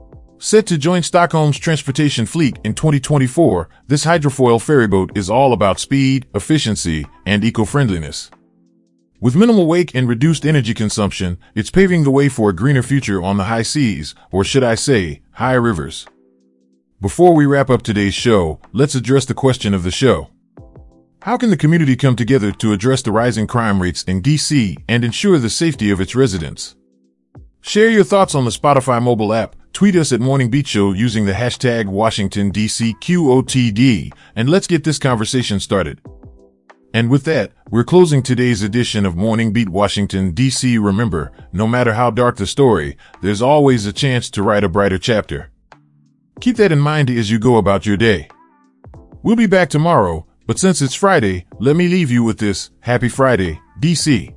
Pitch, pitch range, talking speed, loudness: 120 Hz, 100-145 Hz, 170 wpm, -15 LUFS